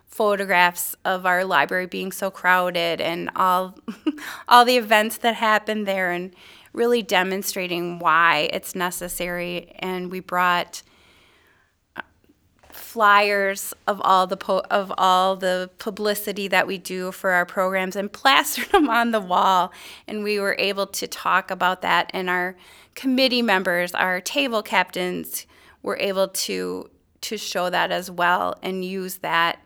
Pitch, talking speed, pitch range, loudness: 185 Hz, 145 wpm, 180-205 Hz, -21 LUFS